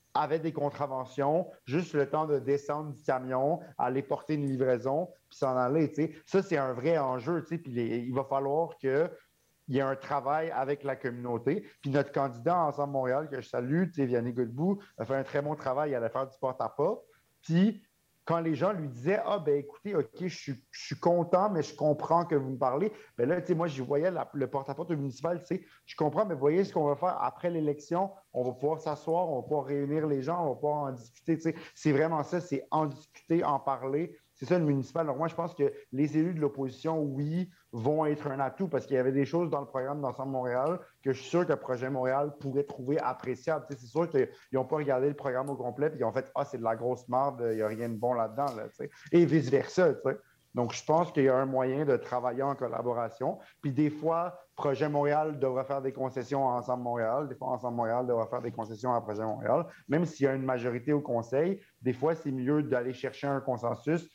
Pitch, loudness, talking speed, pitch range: 140 Hz, -31 LUFS, 240 wpm, 130-160 Hz